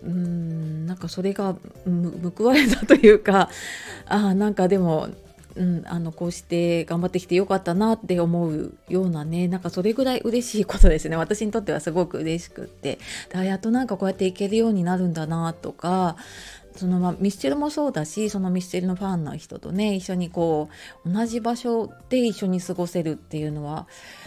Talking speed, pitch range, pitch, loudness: 385 characters per minute, 170-205 Hz, 185 Hz, -23 LUFS